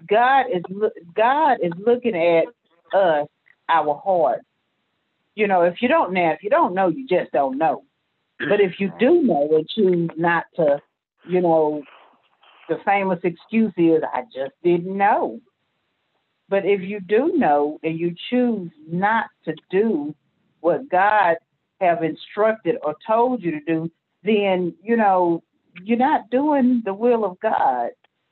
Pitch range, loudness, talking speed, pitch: 165-215 Hz, -20 LUFS, 155 wpm, 180 Hz